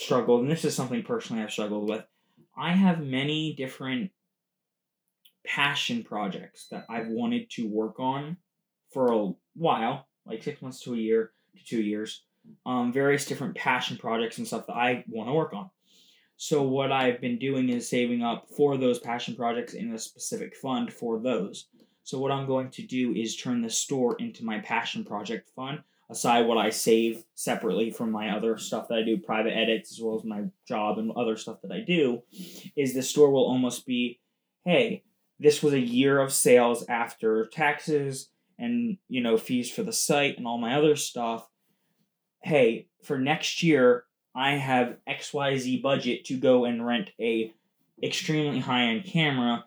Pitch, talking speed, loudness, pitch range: 135 Hz, 180 wpm, -27 LUFS, 120-180 Hz